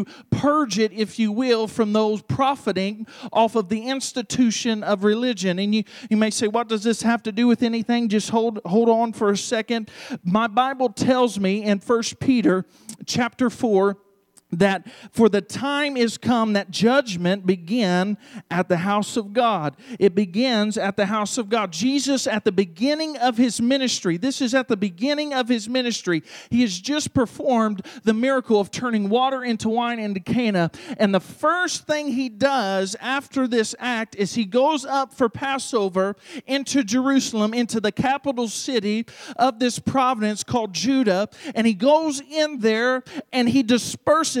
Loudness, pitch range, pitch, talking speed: -22 LUFS, 210-255 Hz, 230 Hz, 170 wpm